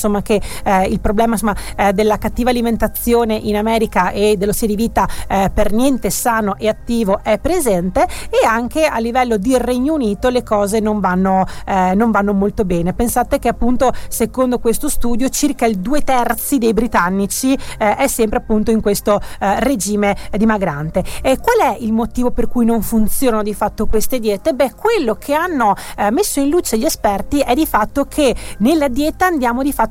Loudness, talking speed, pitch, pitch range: -16 LUFS, 190 wpm, 225 Hz, 210-255 Hz